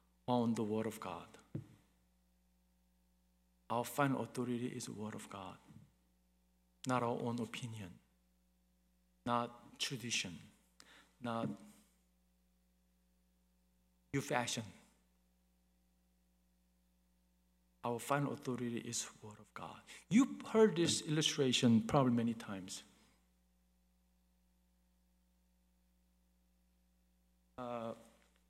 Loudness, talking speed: -38 LUFS, 80 wpm